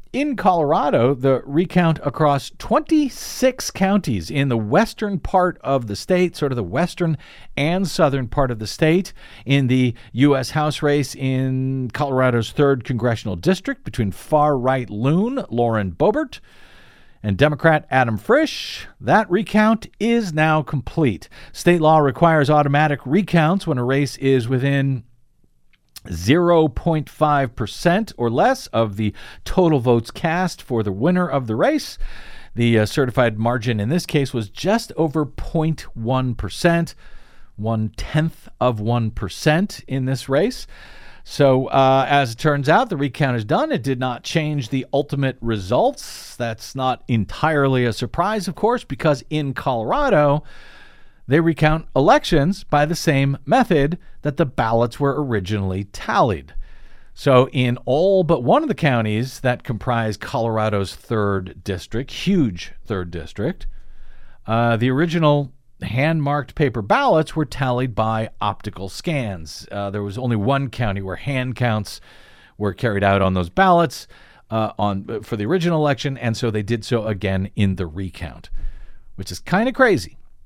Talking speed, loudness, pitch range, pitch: 145 wpm, -20 LUFS, 115-160 Hz, 135 Hz